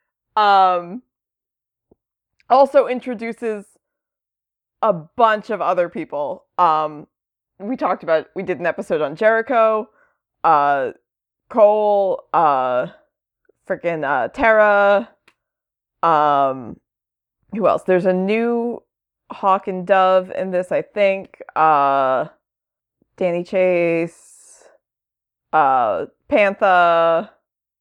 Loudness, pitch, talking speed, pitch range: -18 LUFS, 195 Hz, 95 wpm, 170-225 Hz